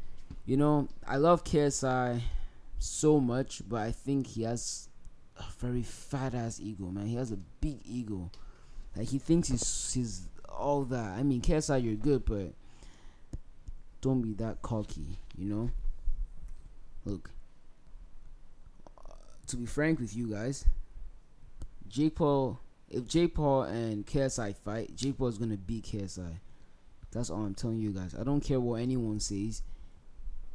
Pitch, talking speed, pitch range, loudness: 115 Hz, 140 wpm, 95-130 Hz, -33 LUFS